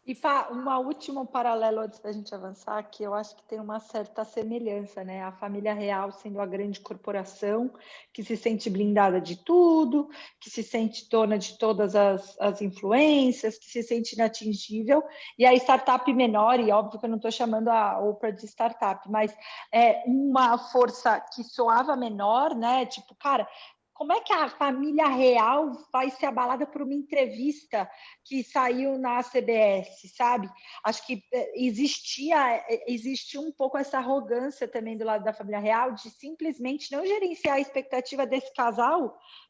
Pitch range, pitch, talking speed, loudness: 215-275 Hz, 240 Hz, 165 wpm, -26 LUFS